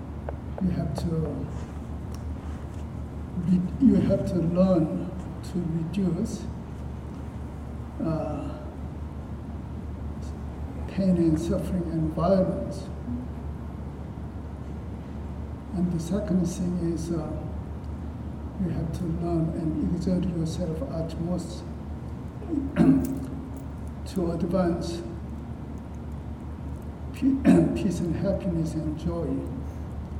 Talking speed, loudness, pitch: 75 wpm, -29 LUFS, 85 Hz